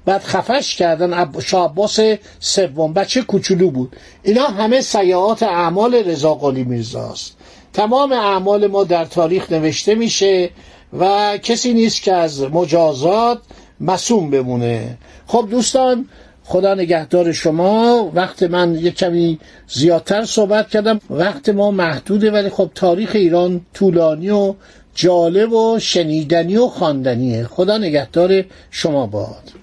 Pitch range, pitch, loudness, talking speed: 170-215 Hz, 185 Hz, -15 LUFS, 120 wpm